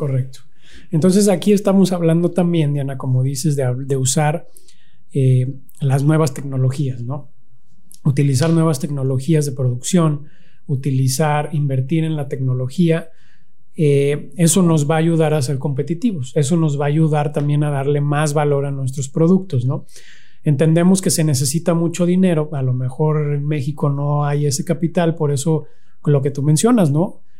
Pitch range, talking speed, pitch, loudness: 140-165 Hz, 160 wpm, 150 Hz, -17 LUFS